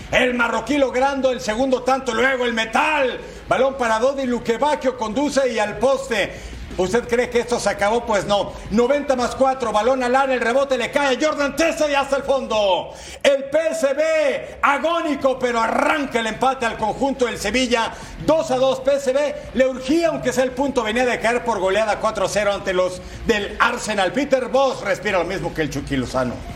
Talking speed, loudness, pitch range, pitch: 190 wpm, -20 LUFS, 225-275 Hz, 255 Hz